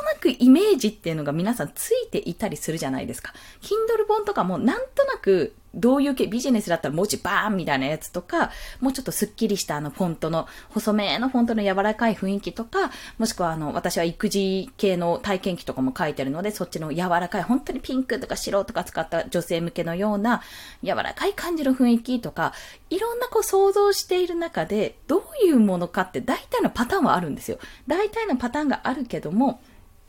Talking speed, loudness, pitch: 445 characters per minute, -24 LUFS, 220 Hz